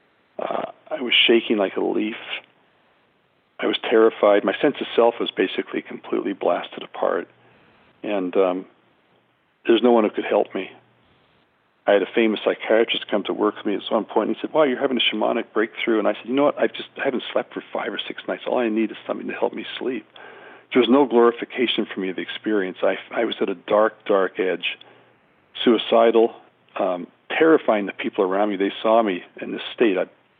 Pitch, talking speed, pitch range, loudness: 110 Hz, 215 wpm, 100-115 Hz, -21 LUFS